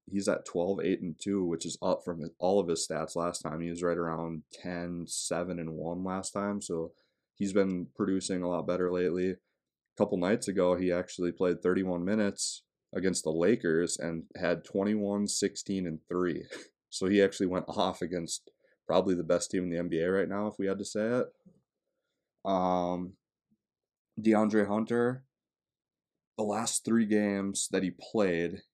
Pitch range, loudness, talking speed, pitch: 85-100 Hz, -31 LUFS, 175 wpm, 90 Hz